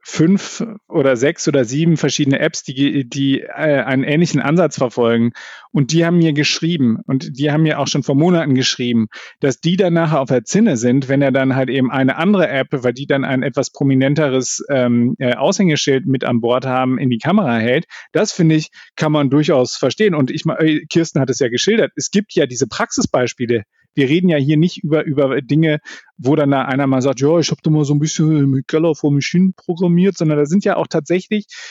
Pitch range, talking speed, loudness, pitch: 130-165 Hz, 210 wpm, -16 LUFS, 145 Hz